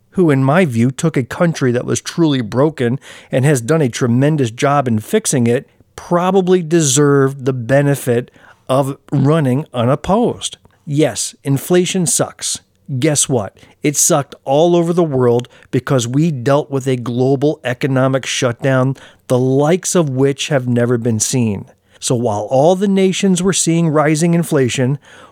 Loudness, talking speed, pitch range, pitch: -15 LUFS, 150 wpm, 125-160 Hz, 140 Hz